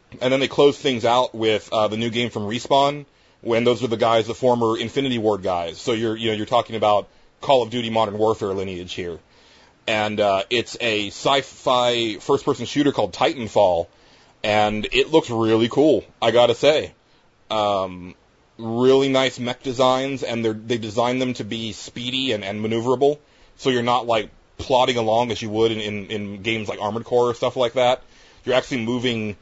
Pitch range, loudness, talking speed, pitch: 105-125 Hz, -21 LUFS, 195 wpm, 115 Hz